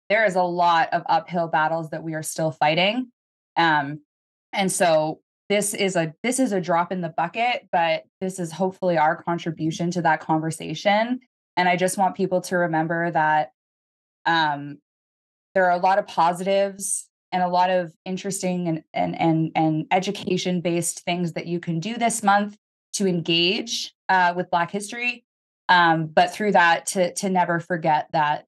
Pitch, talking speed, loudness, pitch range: 175 Hz, 175 wpm, -22 LUFS, 160-190 Hz